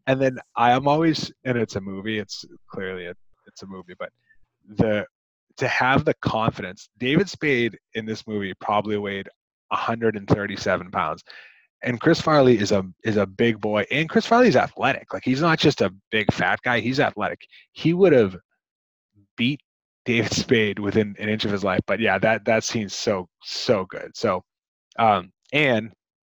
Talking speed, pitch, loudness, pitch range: 170 wpm, 110 Hz, -22 LUFS, 100-130 Hz